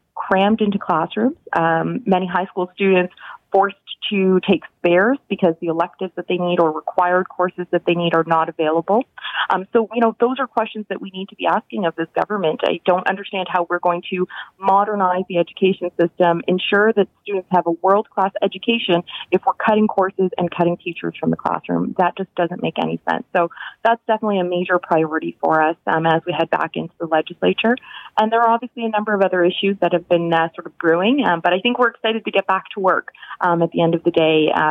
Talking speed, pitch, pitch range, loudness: 220 wpm, 185 Hz, 170-200 Hz, -19 LUFS